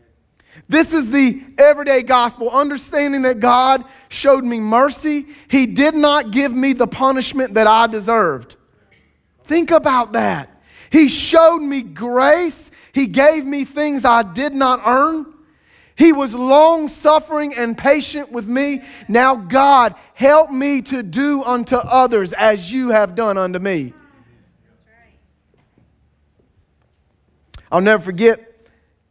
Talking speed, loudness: 125 wpm, -15 LUFS